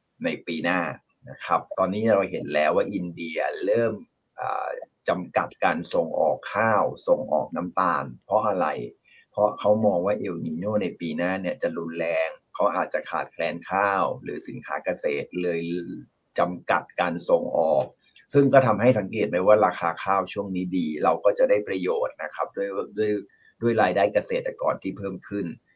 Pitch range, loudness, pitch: 85-125 Hz, -25 LUFS, 100 Hz